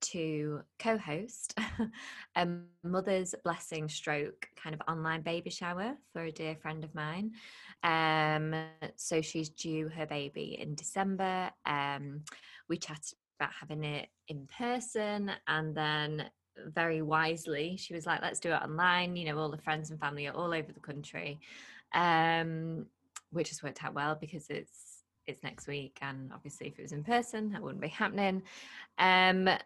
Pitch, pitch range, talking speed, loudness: 160 Hz, 155-185 Hz, 160 wpm, -35 LUFS